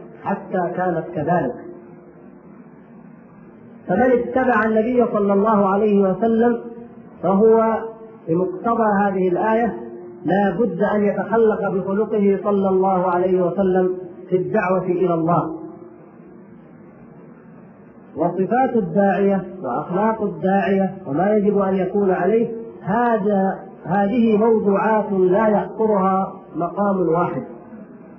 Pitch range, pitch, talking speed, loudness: 185-220 Hz, 200 Hz, 90 wpm, -19 LUFS